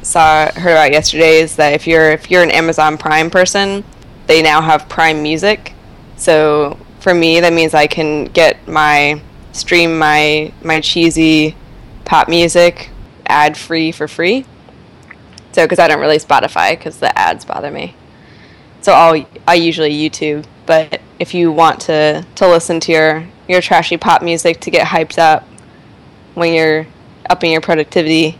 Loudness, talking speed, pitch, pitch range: -11 LUFS, 160 wpm, 160 Hz, 155-170 Hz